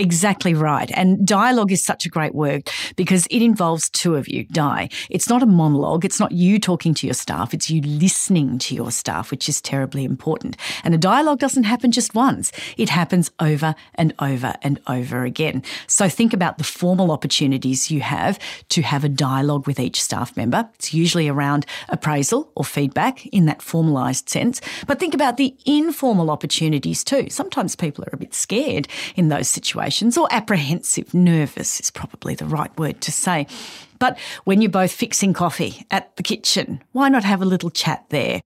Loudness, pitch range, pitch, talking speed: -19 LUFS, 145-205 Hz, 170 Hz, 185 wpm